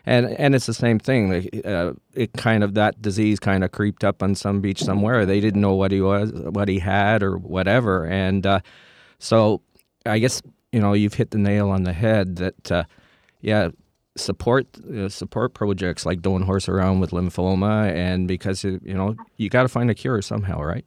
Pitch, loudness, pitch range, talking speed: 100 Hz, -21 LUFS, 95-110 Hz, 205 wpm